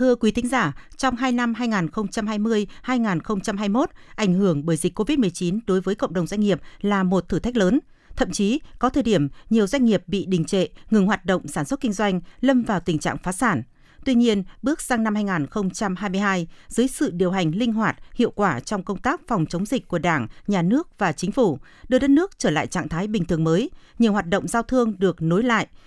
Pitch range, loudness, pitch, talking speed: 185-240 Hz, -22 LUFS, 205 Hz, 215 wpm